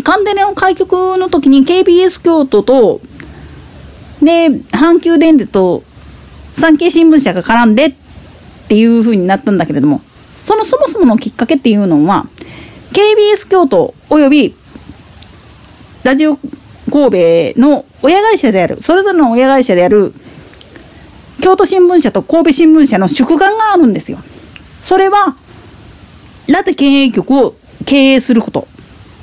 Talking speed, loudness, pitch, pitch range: 265 characters per minute, -9 LUFS, 295 Hz, 240-365 Hz